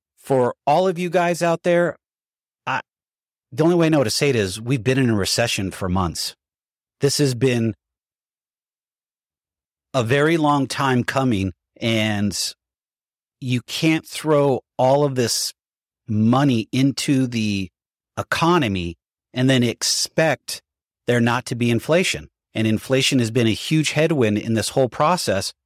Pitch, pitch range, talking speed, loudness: 125 Hz, 110-145 Hz, 145 wpm, -20 LUFS